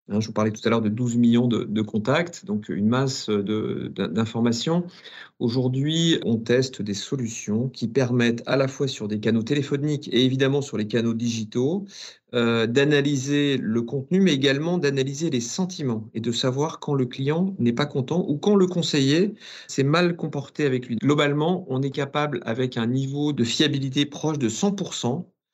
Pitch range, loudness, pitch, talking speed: 115-150 Hz, -23 LUFS, 135 Hz, 180 wpm